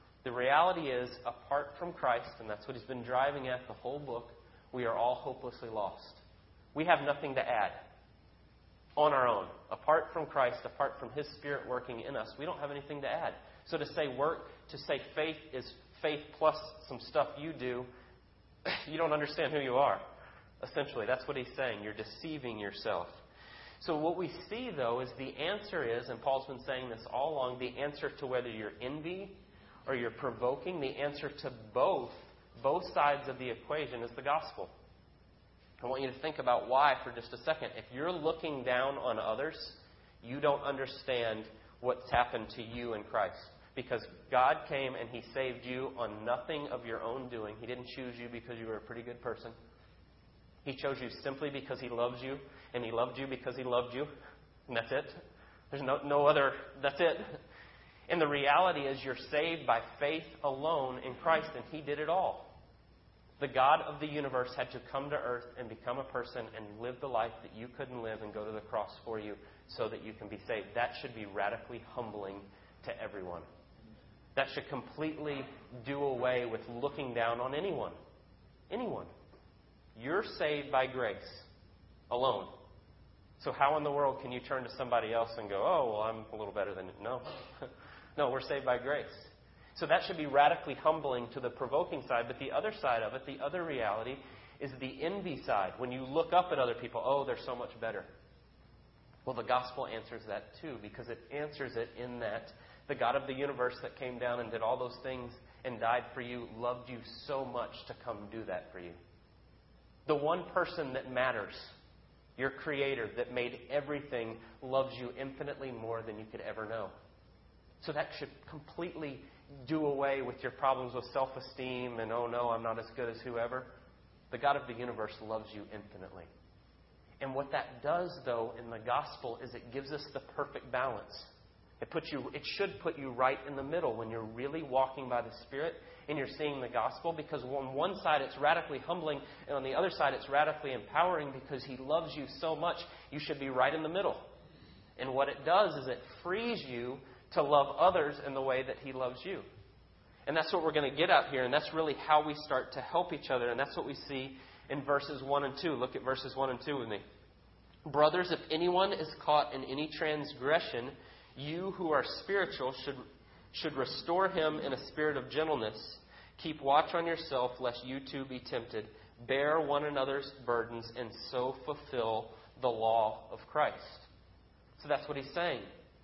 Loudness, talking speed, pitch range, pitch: -36 LUFS, 195 wpm, 120-145 Hz, 130 Hz